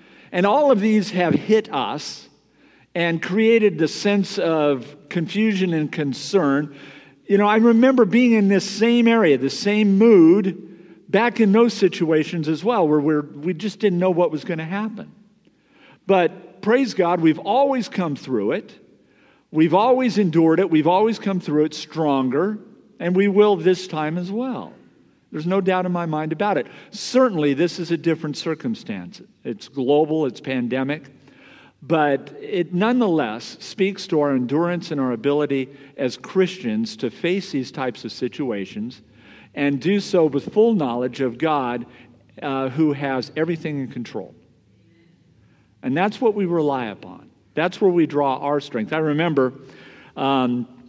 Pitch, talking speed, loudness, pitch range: 170 Hz, 160 wpm, -20 LUFS, 145-205 Hz